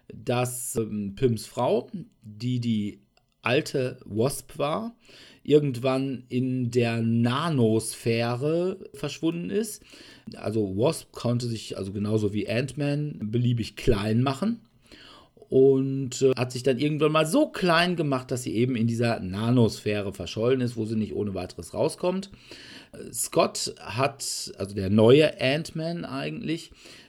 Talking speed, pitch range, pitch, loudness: 120 wpm, 110-145 Hz, 125 Hz, -26 LUFS